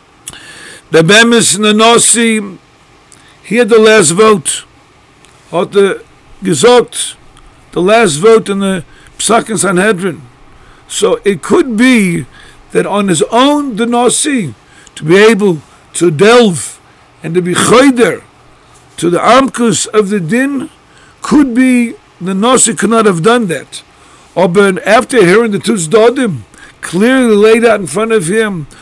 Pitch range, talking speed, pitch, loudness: 180-235 Hz, 140 wpm, 215 Hz, -9 LUFS